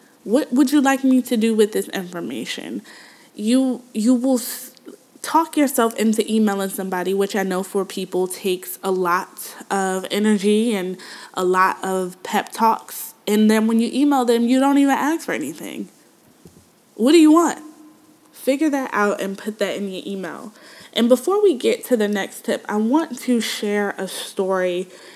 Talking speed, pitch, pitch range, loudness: 175 wpm, 225 Hz, 195-270 Hz, -20 LUFS